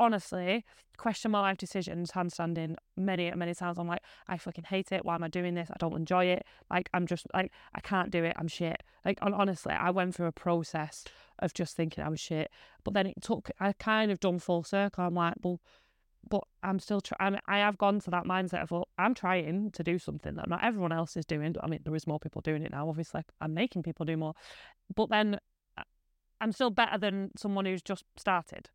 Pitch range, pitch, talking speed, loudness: 170-200 Hz, 180 Hz, 230 wpm, -33 LUFS